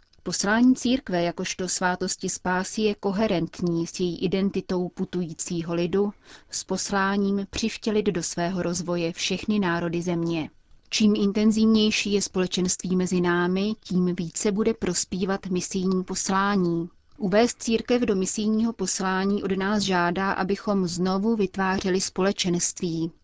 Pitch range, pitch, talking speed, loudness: 180-205 Hz, 190 Hz, 115 wpm, -25 LUFS